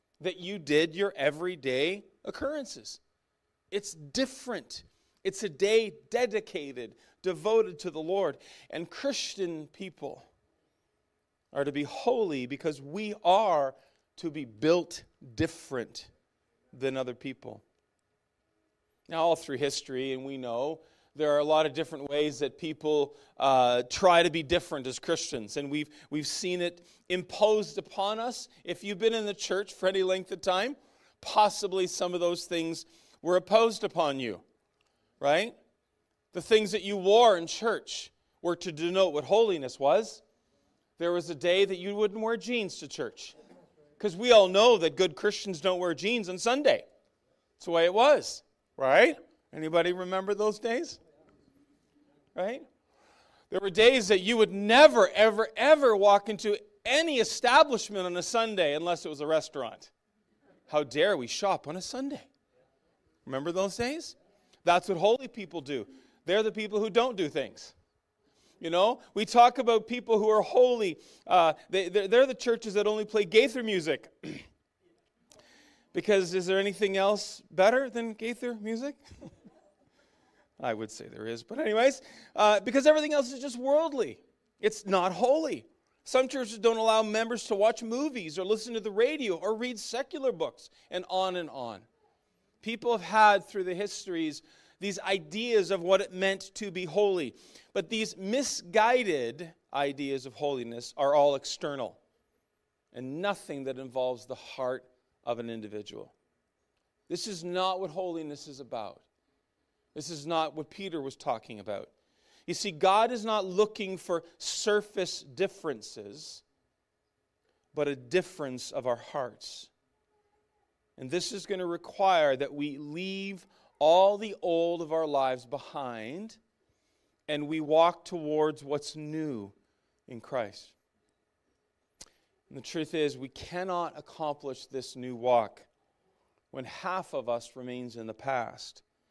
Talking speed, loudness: 150 wpm, -29 LUFS